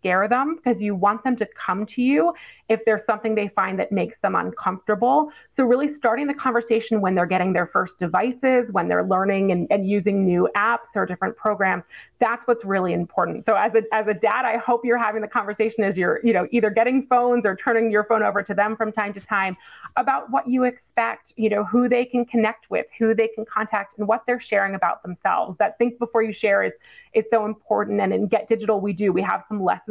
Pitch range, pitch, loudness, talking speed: 200-240 Hz, 220 Hz, -22 LUFS, 230 wpm